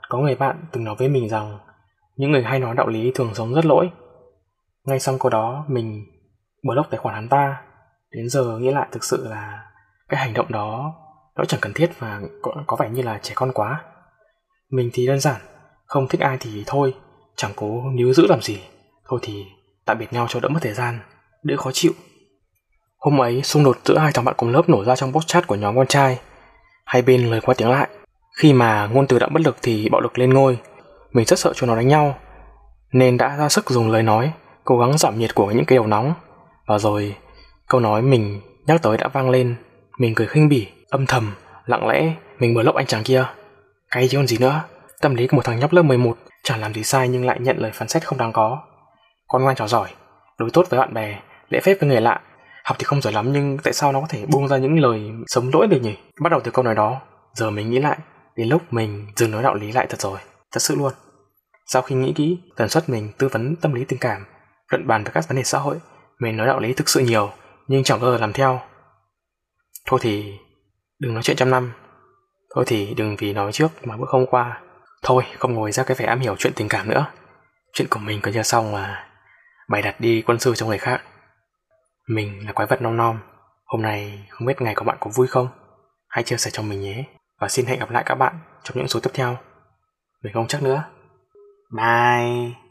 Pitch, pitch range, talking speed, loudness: 125 Hz, 110-135 Hz, 235 wpm, -20 LUFS